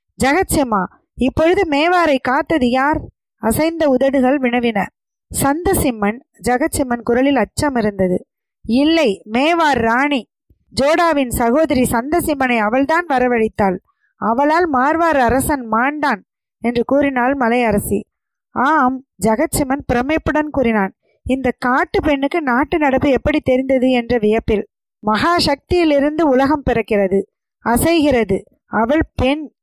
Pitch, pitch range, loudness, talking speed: 265 Hz, 240-305 Hz, -16 LUFS, 95 wpm